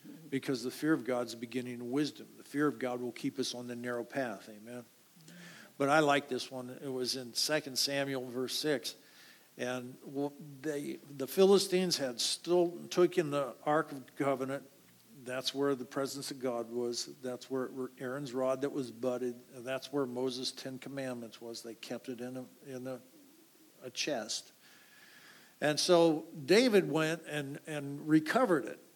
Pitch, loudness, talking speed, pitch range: 135 Hz, -34 LUFS, 175 wpm, 125-150 Hz